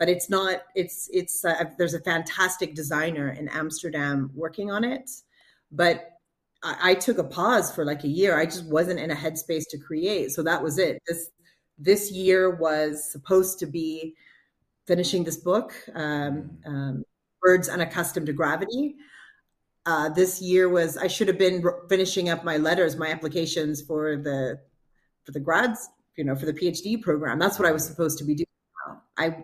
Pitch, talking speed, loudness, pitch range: 170 Hz, 180 wpm, -25 LUFS, 155-185 Hz